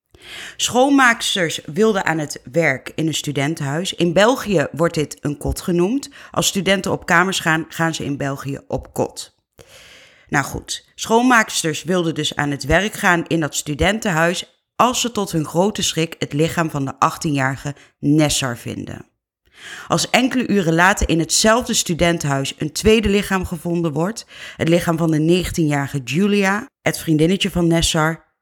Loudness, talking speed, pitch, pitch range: -18 LUFS, 155 wpm, 165 Hz, 155-195 Hz